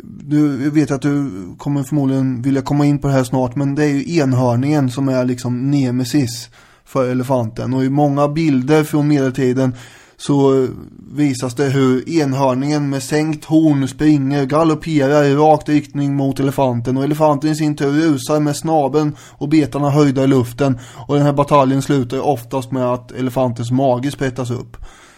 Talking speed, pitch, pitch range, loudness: 170 wpm, 140 Hz, 130-150 Hz, -16 LUFS